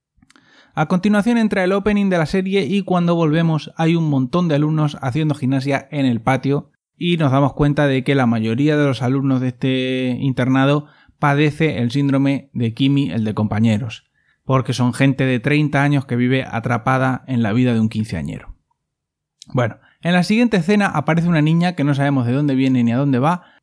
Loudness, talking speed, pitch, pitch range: -18 LUFS, 195 wpm, 140 Hz, 130-160 Hz